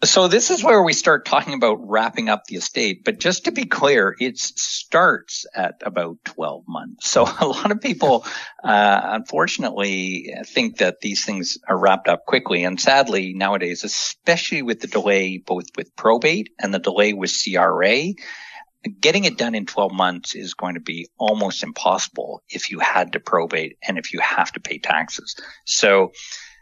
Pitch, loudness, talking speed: 100 Hz, -19 LUFS, 175 wpm